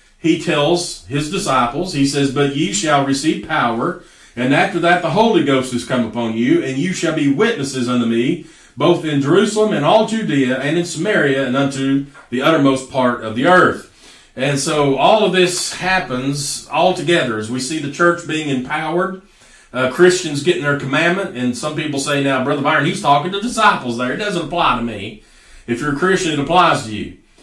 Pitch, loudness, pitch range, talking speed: 145 Hz, -16 LUFS, 130-175 Hz, 195 wpm